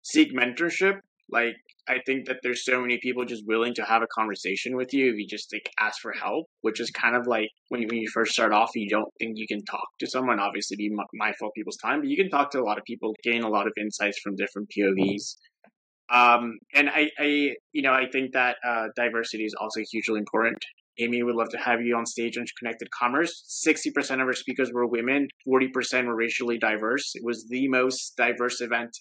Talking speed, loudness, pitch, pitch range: 230 wpm, -26 LUFS, 120 Hz, 110-130 Hz